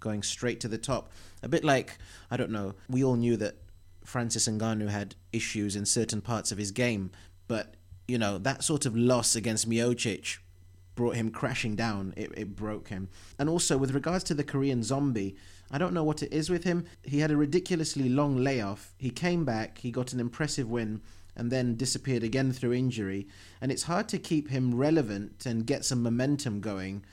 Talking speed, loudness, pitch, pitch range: 200 wpm, -30 LUFS, 120 Hz, 100-135 Hz